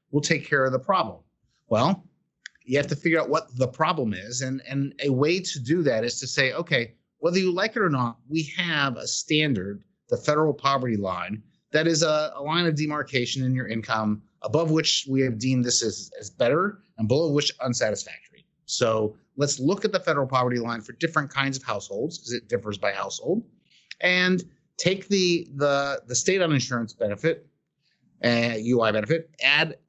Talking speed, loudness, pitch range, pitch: 190 wpm, -25 LUFS, 125-165 Hz, 145 Hz